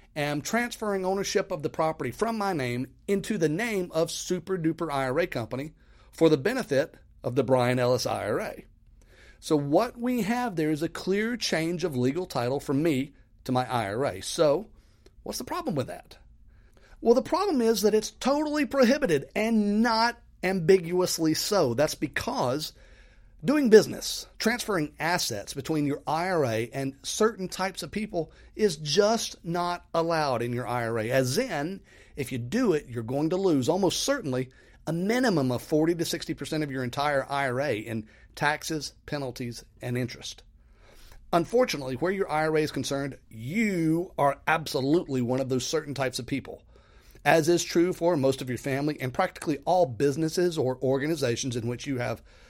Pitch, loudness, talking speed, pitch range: 155 Hz, -27 LUFS, 165 wpm, 130-185 Hz